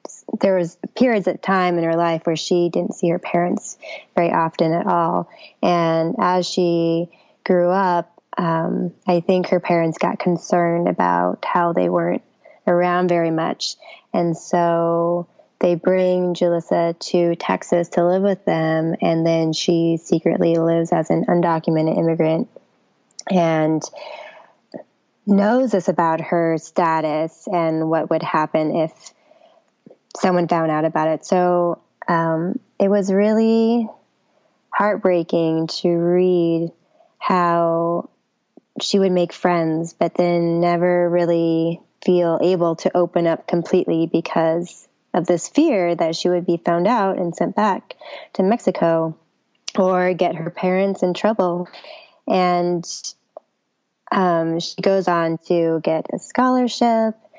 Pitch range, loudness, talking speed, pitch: 165-185 Hz, -19 LUFS, 130 wpm, 175 Hz